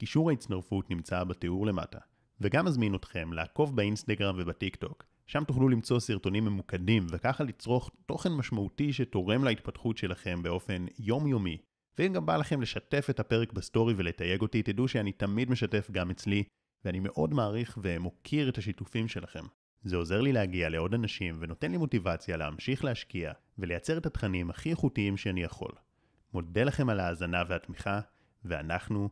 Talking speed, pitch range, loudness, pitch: 150 wpm, 90-120 Hz, -32 LUFS, 105 Hz